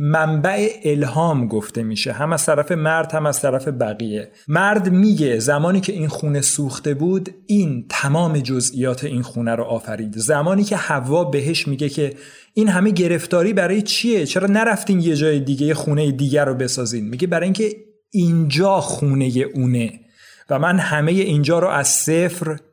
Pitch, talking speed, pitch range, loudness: 155 Hz, 160 wpm, 140-180 Hz, -18 LUFS